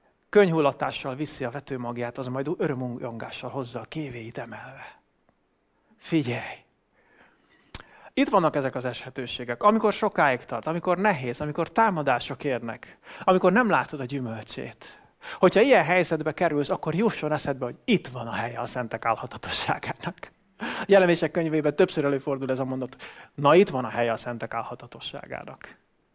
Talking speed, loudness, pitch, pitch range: 140 wpm, -25 LUFS, 140 Hz, 120-170 Hz